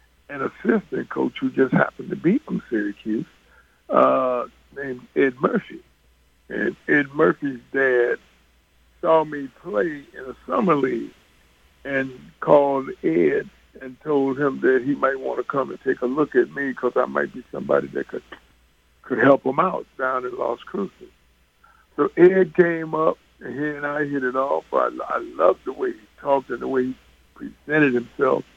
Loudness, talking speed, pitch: -22 LUFS, 170 wpm, 135 Hz